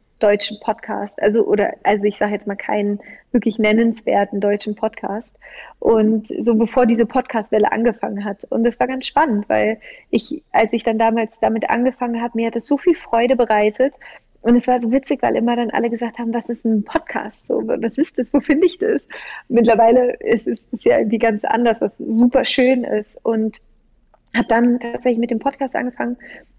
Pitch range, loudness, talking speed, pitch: 215-255 Hz, -18 LUFS, 190 wpm, 235 Hz